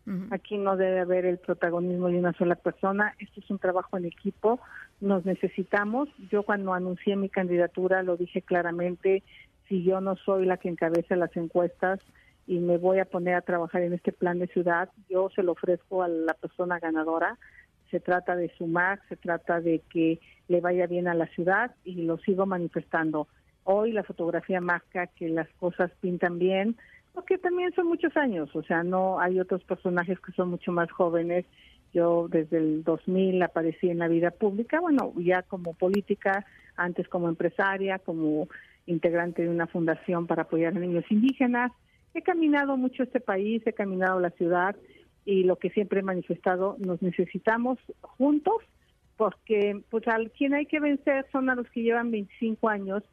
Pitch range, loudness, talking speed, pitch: 175-205 Hz, -28 LUFS, 175 wpm, 185 Hz